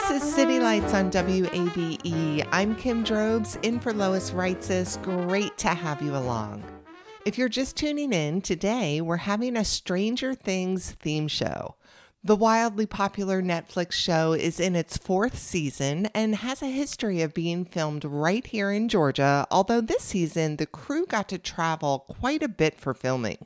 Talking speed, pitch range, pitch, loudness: 165 wpm, 160-220 Hz, 185 Hz, -26 LUFS